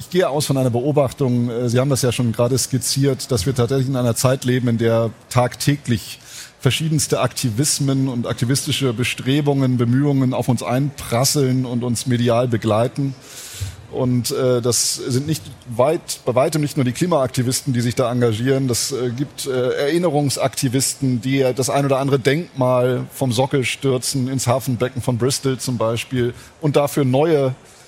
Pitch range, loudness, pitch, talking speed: 125-140 Hz, -19 LUFS, 130 Hz, 155 wpm